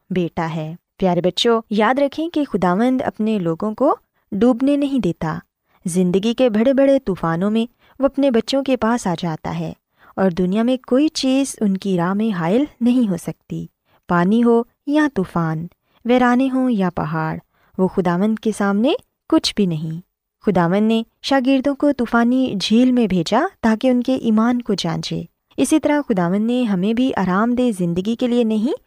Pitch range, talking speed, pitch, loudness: 185-255 Hz, 170 wpm, 225 Hz, -18 LUFS